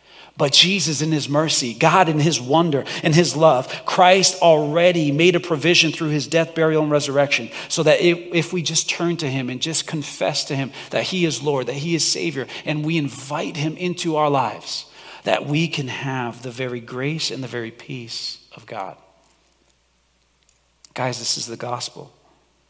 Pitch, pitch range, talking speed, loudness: 150 Hz, 130-165 Hz, 180 wpm, -19 LUFS